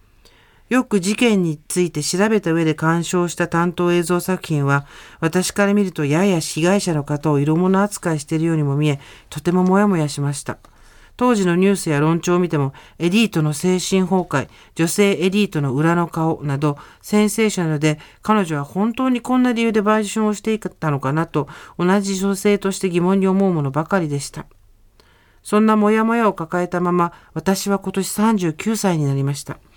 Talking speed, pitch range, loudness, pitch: 345 characters per minute, 155-200 Hz, -19 LUFS, 175 Hz